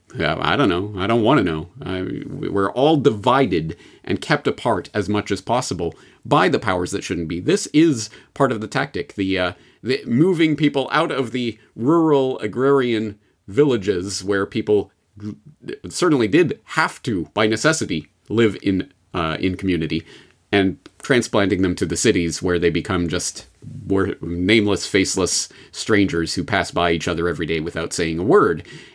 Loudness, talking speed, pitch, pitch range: -20 LUFS, 160 wpm, 100 Hz, 90-115 Hz